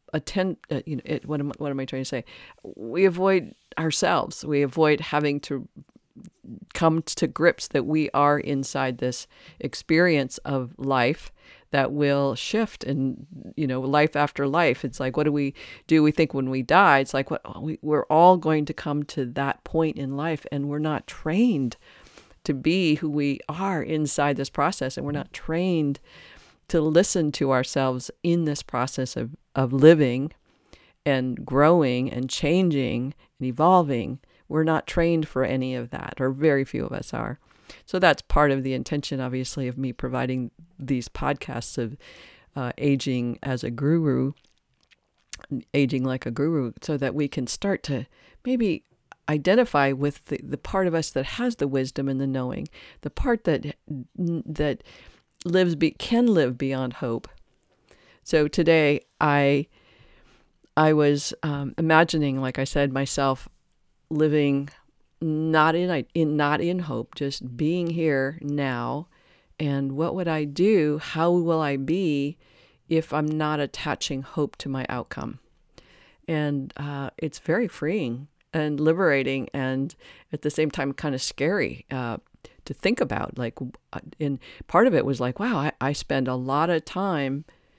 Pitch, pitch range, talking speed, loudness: 145 Hz, 135-160 Hz, 160 wpm, -24 LUFS